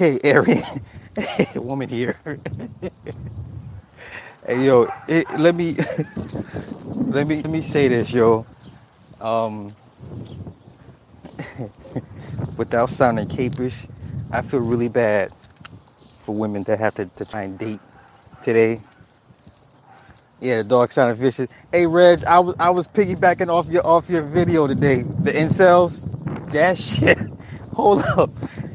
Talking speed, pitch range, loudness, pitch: 120 wpm, 115-155 Hz, -19 LUFS, 130 Hz